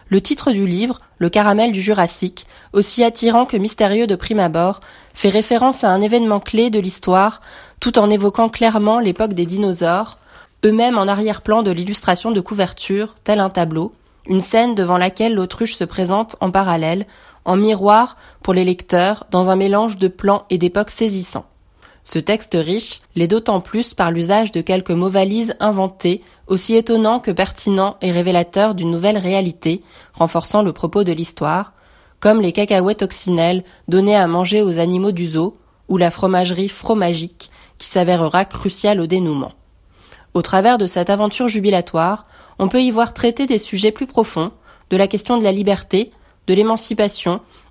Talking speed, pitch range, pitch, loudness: 165 wpm, 180-215 Hz, 195 Hz, -16 LUFS